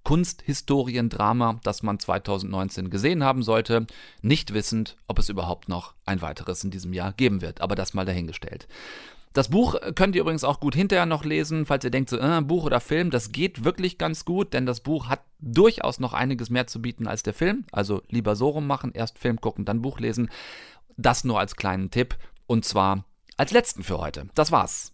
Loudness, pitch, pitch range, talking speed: -25 LUFS, 120 Hz, 100-145 Hz, 200 wpm